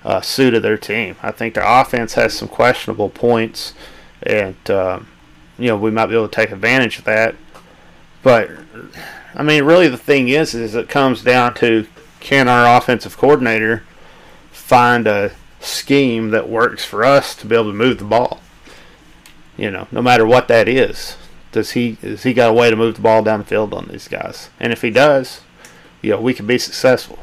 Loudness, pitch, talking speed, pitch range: -15 LUFS, 115 Hz, 200 wpm, 110-130 Hz